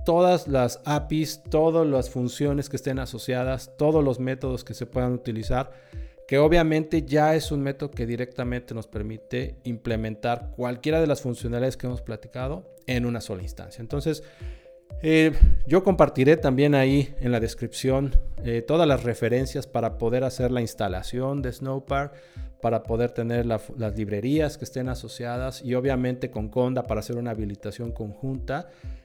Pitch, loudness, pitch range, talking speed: 125 Hz, -25 LUFS, 120-140 Hz, 155 wpm